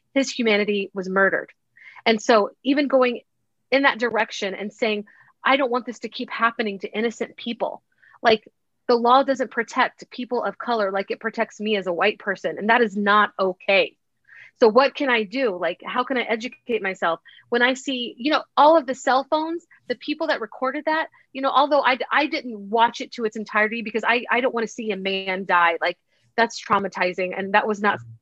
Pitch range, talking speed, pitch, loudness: 205-260 Hz, 210 wpm, 230 Hz, -22 LUFS